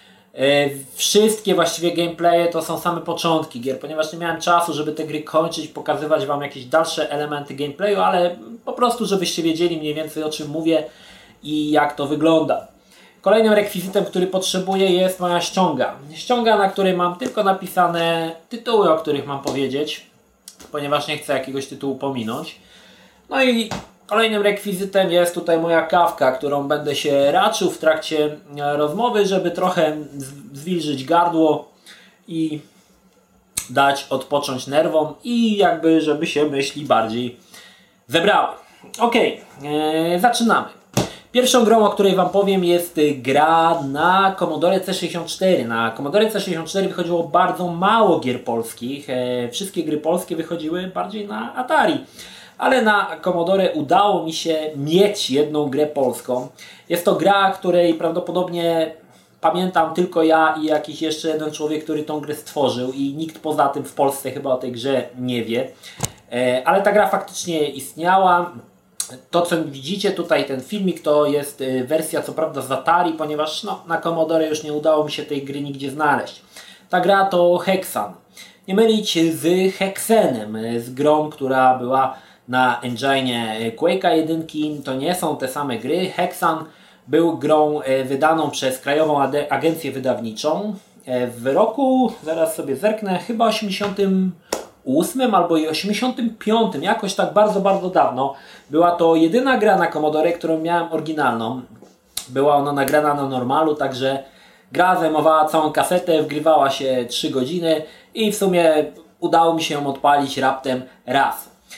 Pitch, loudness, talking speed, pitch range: 160 Hz, -19 LUFS, 145 wpm, 145-180 Hz